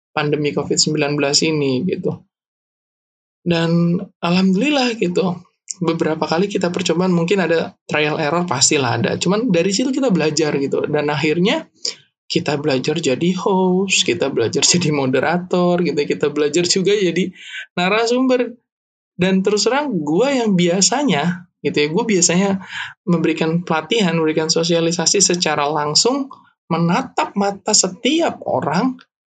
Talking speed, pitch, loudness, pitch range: 120 wpm, 175 Hz, -17 LUFS, 155-195 Hz